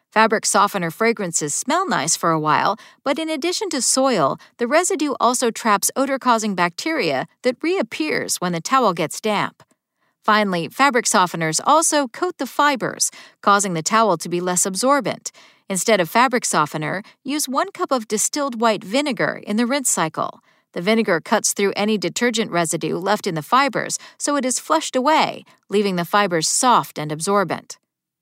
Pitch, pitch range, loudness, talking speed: 220 Hz, 180-270 Hz, -19 LUFS, 165 wpm